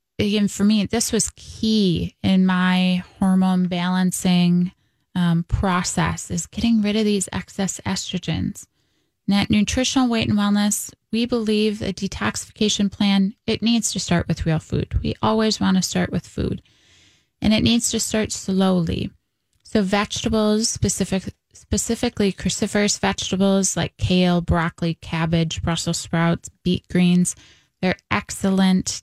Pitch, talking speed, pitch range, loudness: 195 Hz, 135 wpm, 180-215 Hz, -21 LUFS